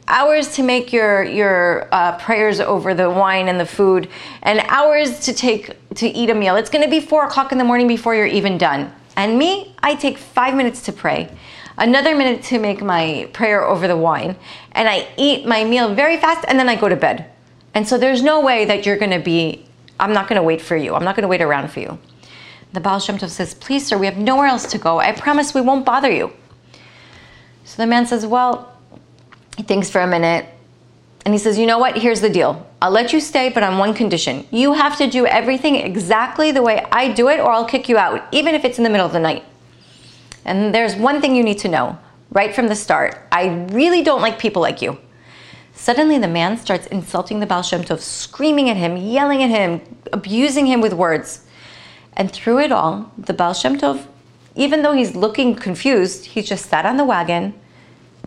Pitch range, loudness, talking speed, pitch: 190-260 Hz, -16 LUFS, 220 wpm, 220 Hz